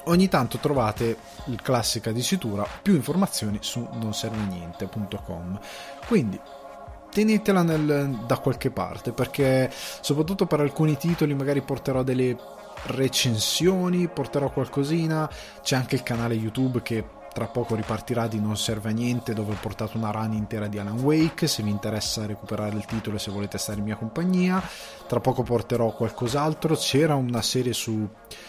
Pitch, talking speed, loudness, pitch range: 120 Hz, 150 wpm, -25 LUFS, 110-145 Hz